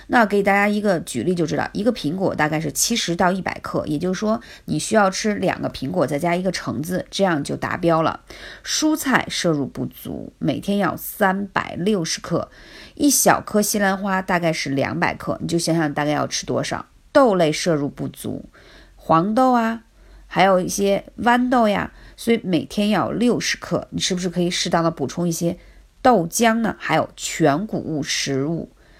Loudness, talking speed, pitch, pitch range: -20 LUFS, 270 characters per minute, 190 Hz, 165-215 Hz